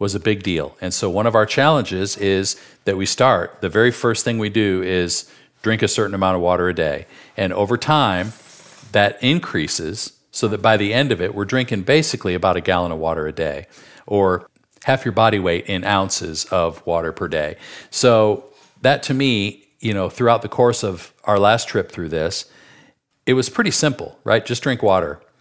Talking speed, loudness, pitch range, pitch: 200 wpm, -19 LUFS, 95-120 Hz, 105 Hz